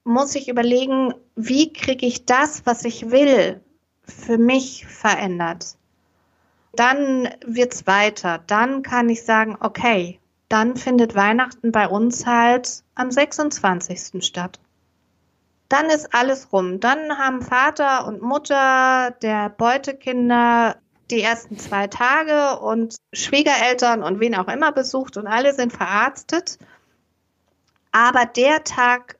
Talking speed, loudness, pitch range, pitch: 125 wpm, -19 LUFS, 210-265 Hz, 240 Hz